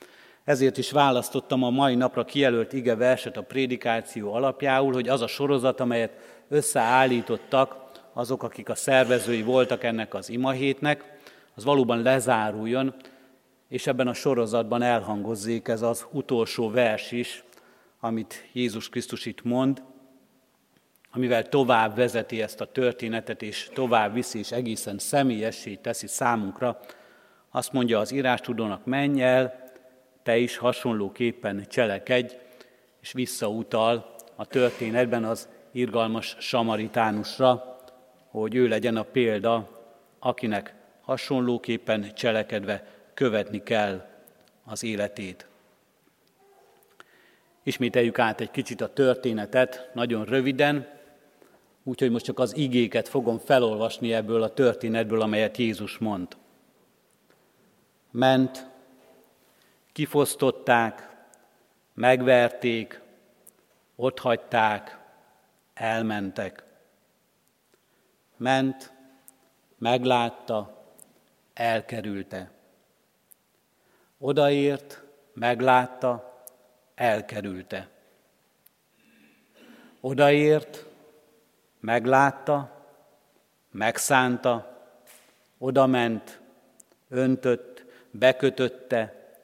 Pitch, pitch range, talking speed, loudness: 125 Hz, 115-130 Hz, 85 wpm, -25 LUFS